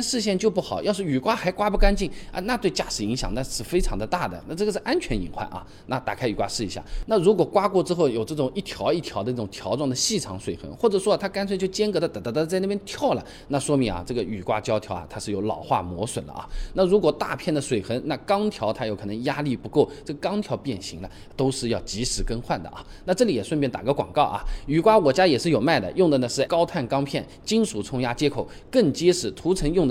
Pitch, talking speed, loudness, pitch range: 145 Hz, 370 characters per minute, -24 LUFS, 115-190 Hz